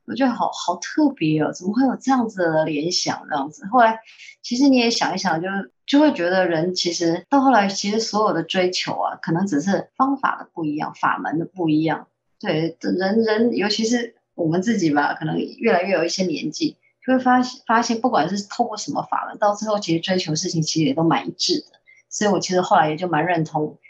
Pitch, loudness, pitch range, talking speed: 195 Hz, -21 LUFS, 165-240 Hz, 325 characters per minute